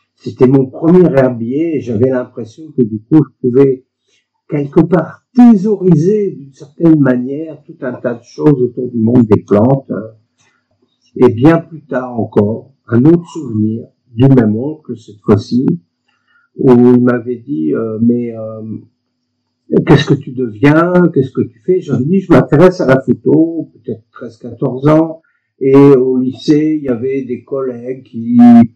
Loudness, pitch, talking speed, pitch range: -11 LUFS, 130 Hz, 155 wpm, 120-155 Hz